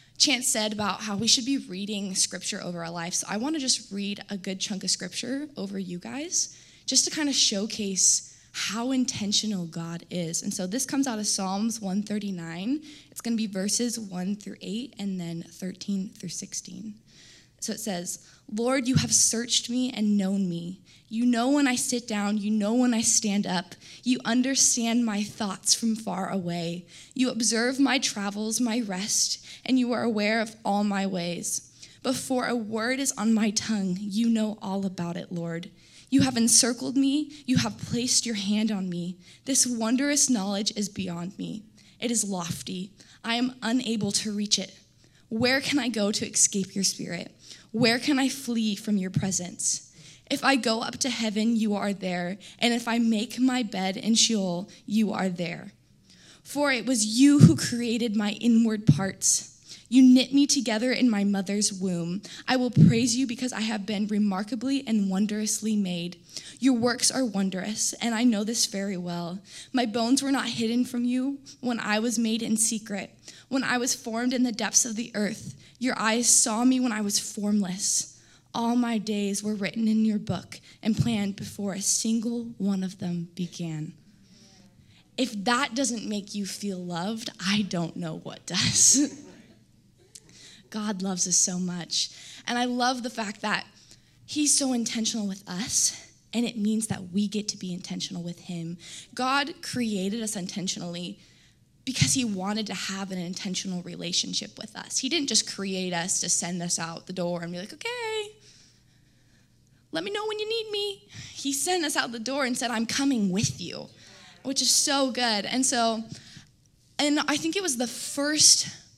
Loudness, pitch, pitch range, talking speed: -26 LUFS, 215 Hz, 190-245 Hz, 180 wpm